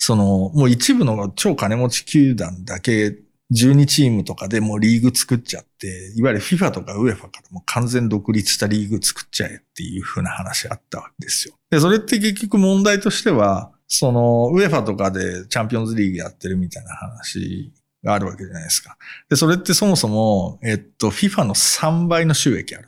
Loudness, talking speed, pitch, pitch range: -18 LUFS, 410 characters per minute, 115 Hz, 100-155 Hz